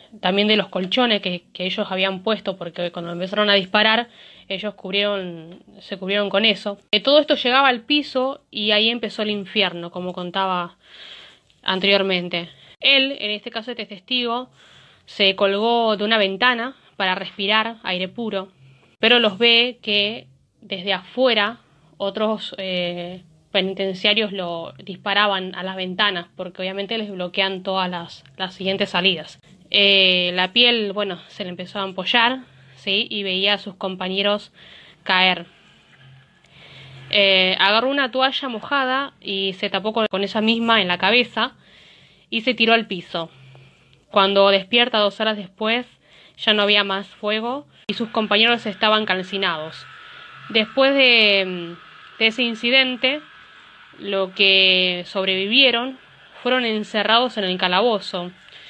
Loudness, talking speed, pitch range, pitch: -19 LUFS, 140 wpm, 185-225 Hz, 200 Hz